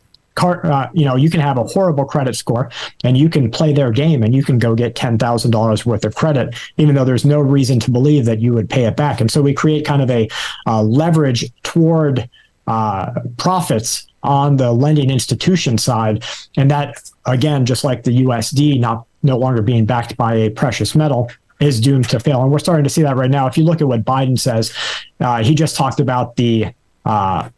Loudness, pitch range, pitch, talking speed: -15 LUFS, 120-145 Hz, 130 Hz, 215 wpm